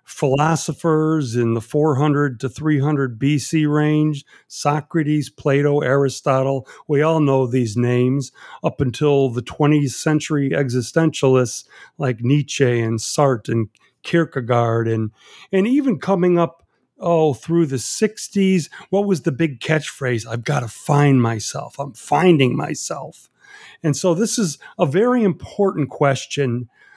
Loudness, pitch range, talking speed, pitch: -19 LUFS, 130-160 Hz, 135 wpm, 145 Hz